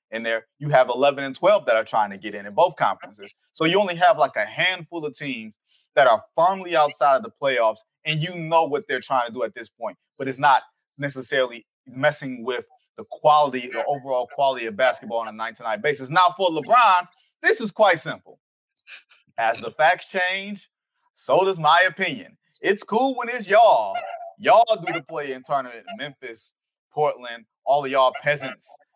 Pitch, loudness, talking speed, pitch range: 155 Hz, -21 LUFS, 195 wpm, 130-220 Hz